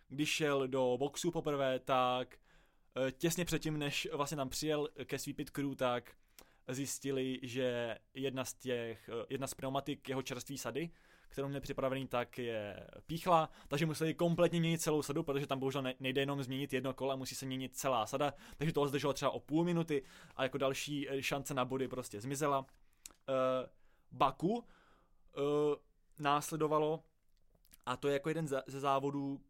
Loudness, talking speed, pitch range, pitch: -37 LUFS, 155 wpm, 130-150 Hz, 140 Hz